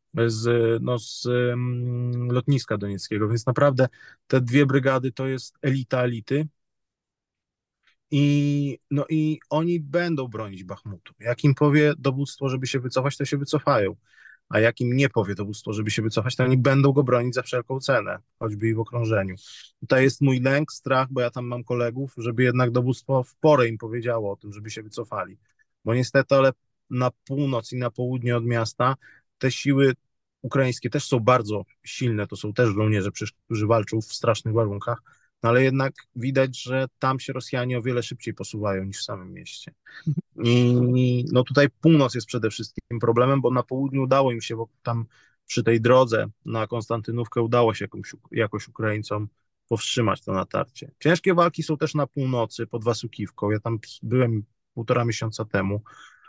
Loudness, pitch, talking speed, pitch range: -24 LUFS, 125 Hz, 170 wpm, 115-135 Hz